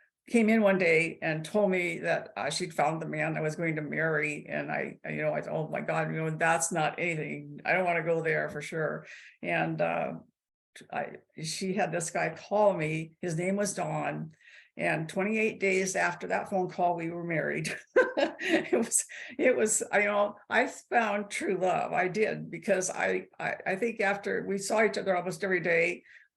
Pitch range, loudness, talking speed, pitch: 160-200 Hz, -29 LUFS, 200 wpm, 175 Hz